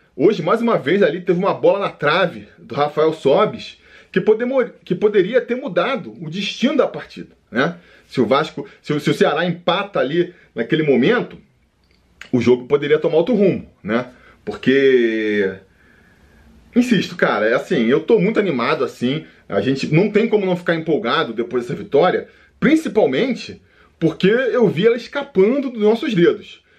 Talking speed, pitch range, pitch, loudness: 165 wpm, 145-220 Hz, 180 Hz, -18 LUFS